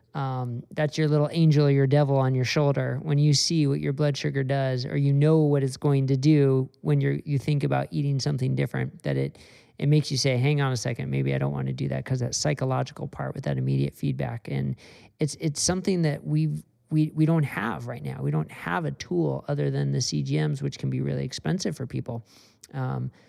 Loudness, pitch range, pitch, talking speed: -25 LUFS, 110-150 Hz, 135 Hz, 230 wpm